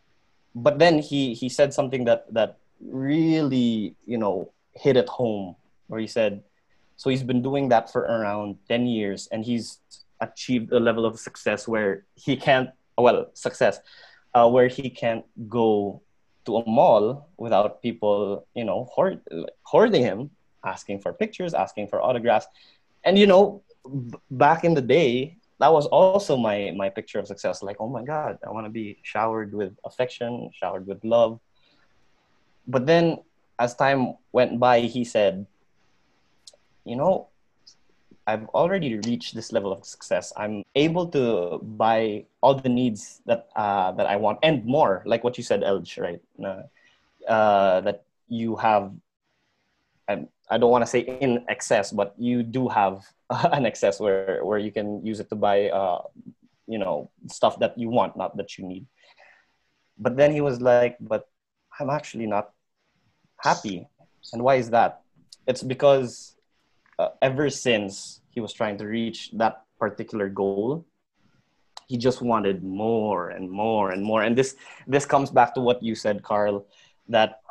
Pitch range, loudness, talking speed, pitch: 105-130 Hz, -24 LUFS, 160 wpm, 115 Hz